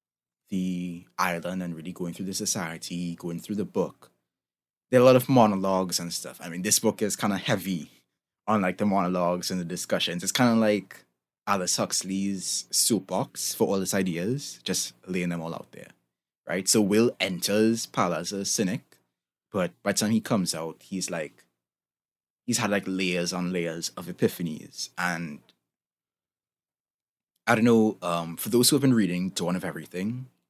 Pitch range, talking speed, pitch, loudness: 85-105 Hz, 180 wpm, 90 Hz, -26 LUFS